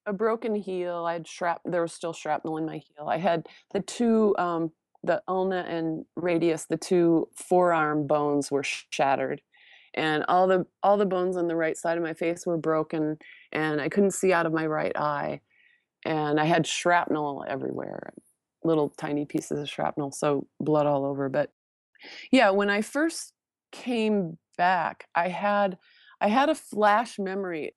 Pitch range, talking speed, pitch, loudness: 155-190 Hz, 175 wpm, 170 Hz, -26 LUFS